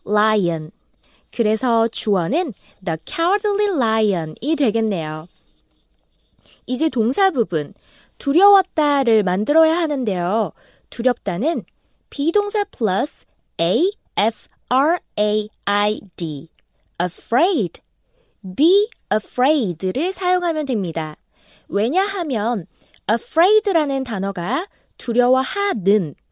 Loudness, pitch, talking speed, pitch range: -19 LUFS, 245 Hz, 245 characters per minute, 200-335 Hz